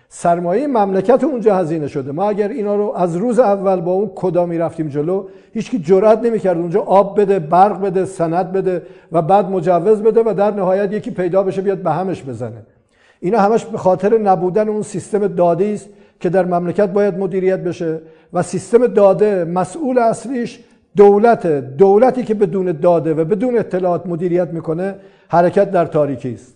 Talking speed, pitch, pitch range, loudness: 175 wpm, 190 Hz, 175-210 Hz, -15 LUFS